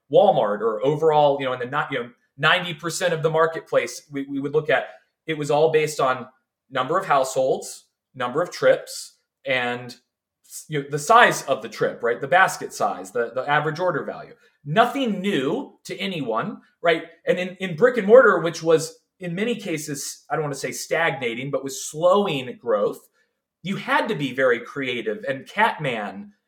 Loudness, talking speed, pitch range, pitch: -22 LUFS, 185 wpm, 145-235 Hz, 165 Hz